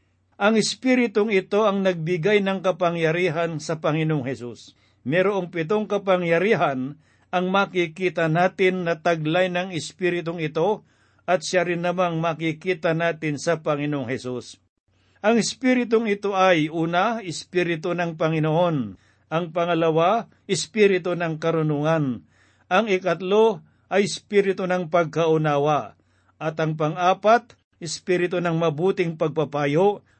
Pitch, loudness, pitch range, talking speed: 170 Hz, -22 LUFS, 155-185 Hz, 110 wpm